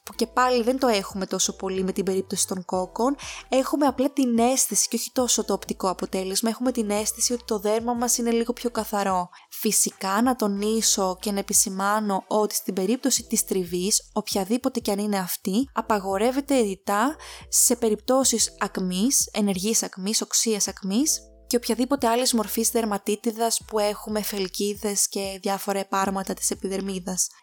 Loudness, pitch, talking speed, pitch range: -24 LUFS, 215 Hz, 160 wpm, 195-240 Hz